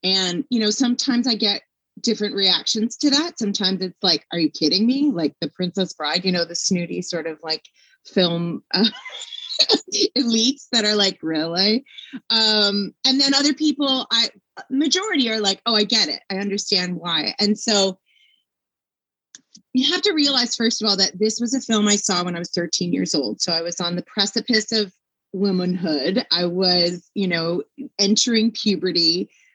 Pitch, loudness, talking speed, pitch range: 210 Hz, -19 LUFS, 175 wpm, 180-250 Hz